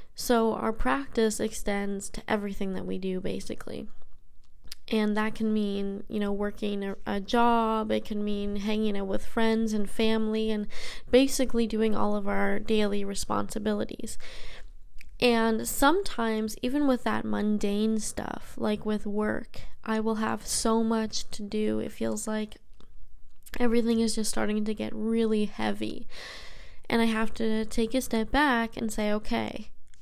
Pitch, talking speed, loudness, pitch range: 215 Hz, 150 wpm, -28 LUFS, 205-225 Hz